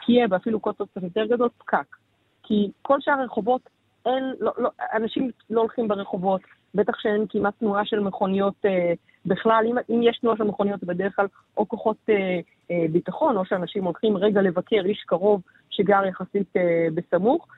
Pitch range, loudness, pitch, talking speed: 195-230 Hz, -24 LUFS, 210 Hz, 165 wpm